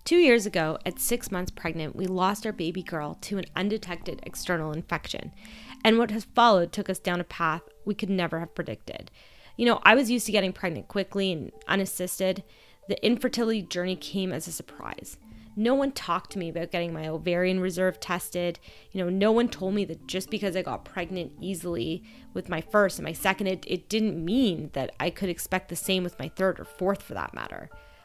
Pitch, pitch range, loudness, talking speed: 185 Hz, 170-205 Hz, -27 LUFS, 210 wpm